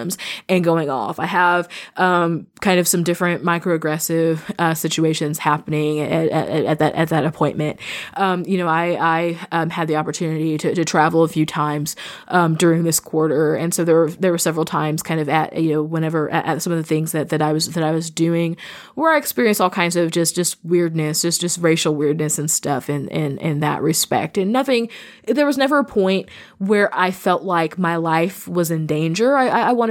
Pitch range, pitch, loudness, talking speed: 155-180 Hz, 165 Hz, -19 LUFS, 215 wpm